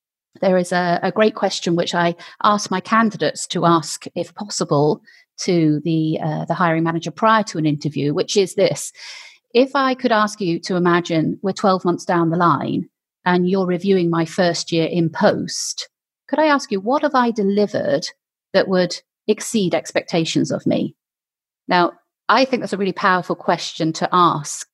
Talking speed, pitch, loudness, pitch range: 175 wpm, 180 Hz, -19 LUFS, 170-210 Hz